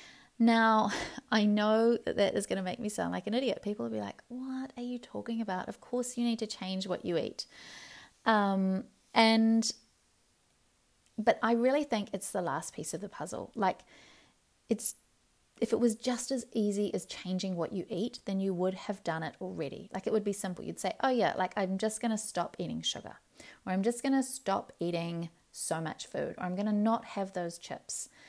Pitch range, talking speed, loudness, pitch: 190-235 Hz, 210 wpm, -32 LUFS, 215 Hz